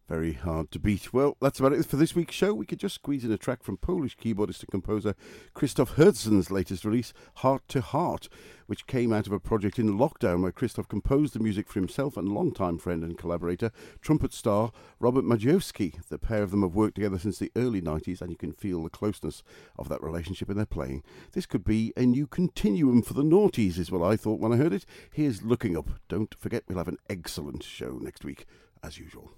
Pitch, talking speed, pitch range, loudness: 105 Hz, 225 wpm, 90-125 Hz, -28 LUFS